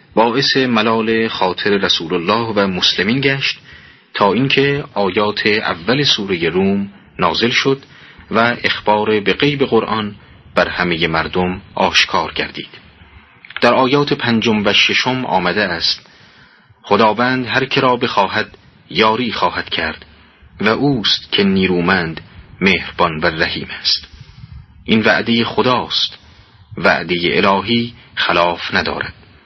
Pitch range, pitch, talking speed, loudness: 95-130 Hz, 110 Hz, 110 wpm, -15 LUFS